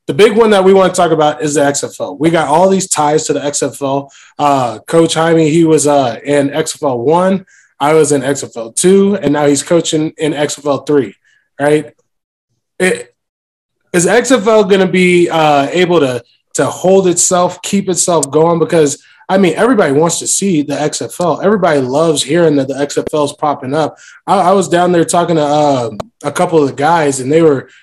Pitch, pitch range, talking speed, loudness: 155 Hz, 145-180 Hz, 195 wpm, -11 LUFS